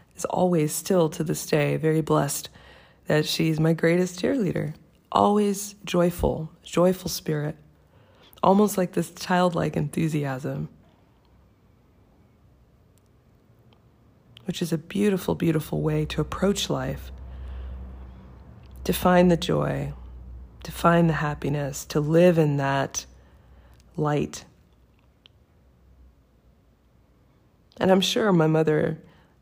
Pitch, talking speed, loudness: 155 Hz, 100 wpm, -24 LUFS